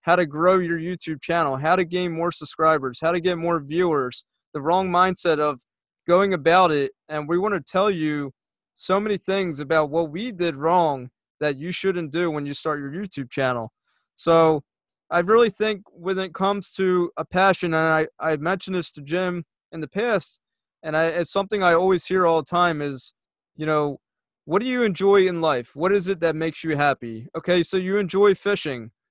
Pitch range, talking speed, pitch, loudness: 155-185 Hz, 200 wpm, 170 Hz, -22 LUFS